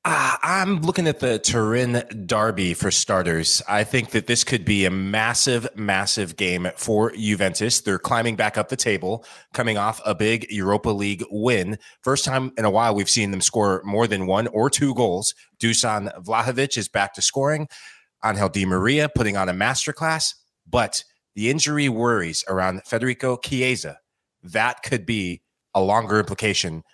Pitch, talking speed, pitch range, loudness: 110 Hz, 165 wpm, 100-125 Hz, -21 LUFS